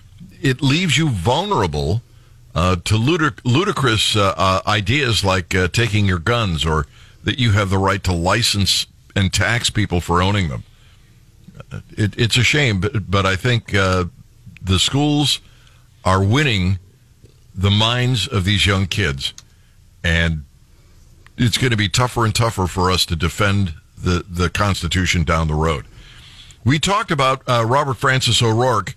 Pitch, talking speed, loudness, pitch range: 105 Hz, 155 wpm, -17 LUFS, 95-120 Hz